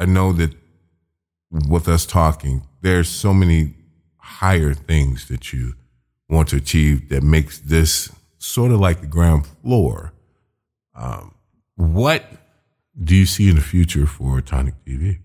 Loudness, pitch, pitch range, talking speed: -18 LUFS, 80 Hz, 75-90 Hz, 140 wpm